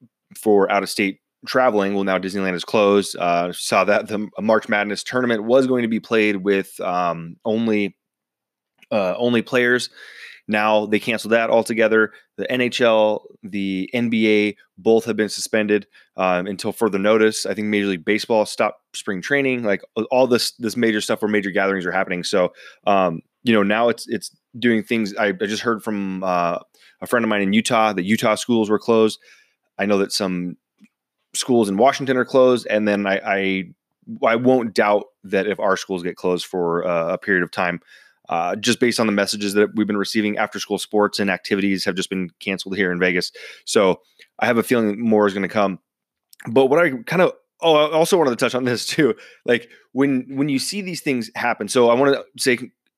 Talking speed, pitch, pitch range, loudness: 200 wpm, 105 Hz, 100-120 Hz, -20 LUFS